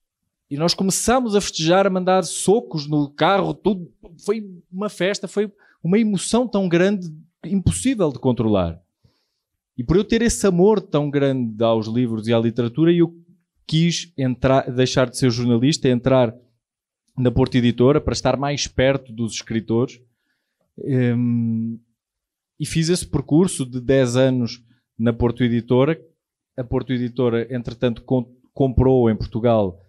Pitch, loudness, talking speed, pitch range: 135 Hz, -20 LUFS, 140 wpm, 120-175 Hz